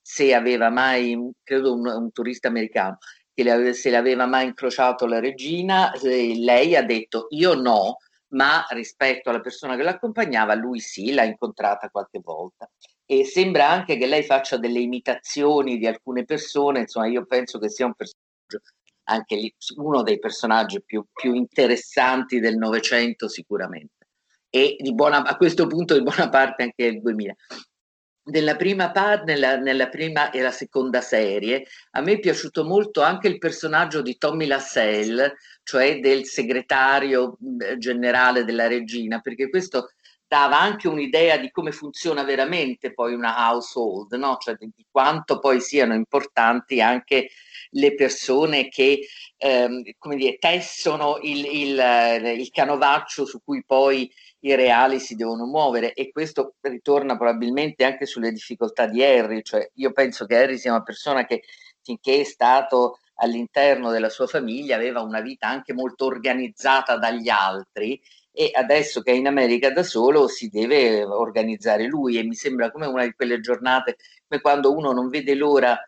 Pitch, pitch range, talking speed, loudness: 130 Hz, 120-145 Hz, 160 wpm, -21 LUFS